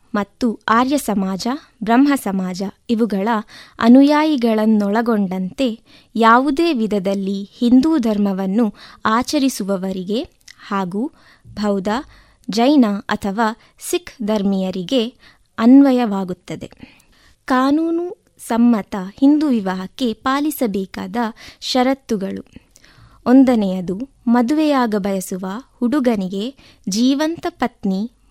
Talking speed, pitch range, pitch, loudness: 65 wpm, 200-265 Hz, 230 Hz, -18 LUFS